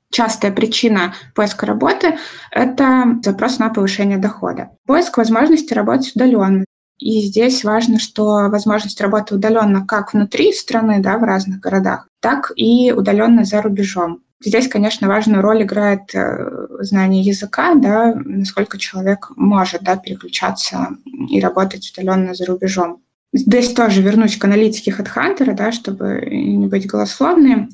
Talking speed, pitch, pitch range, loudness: 130 wpm, 210 Hz, 195-235 Hz, -15 LUFS